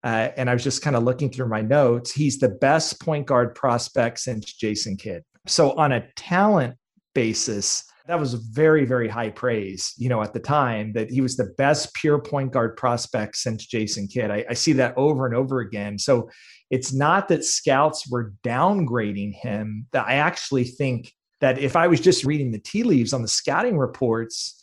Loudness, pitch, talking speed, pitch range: -22 LUFS, 125 Hz, 195 wpm, 115-145 Hz